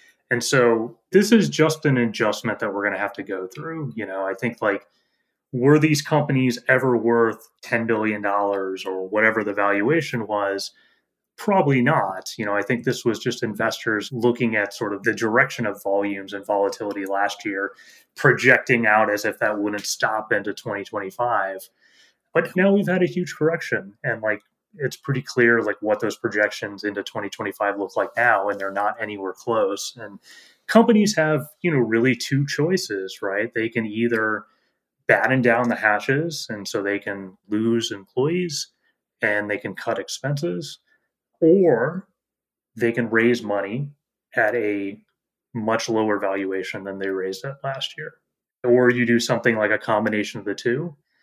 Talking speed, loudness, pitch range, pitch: 170 wpm, -22 LUFS, 100-135 Hz, 115 Hz